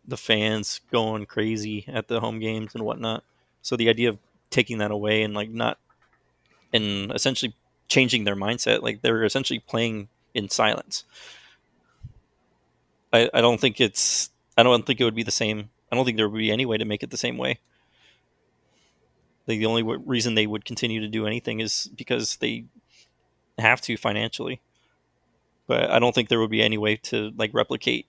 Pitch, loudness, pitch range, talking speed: 110 Hz, -24 LUFS, 110-120 Hz, 185 wpm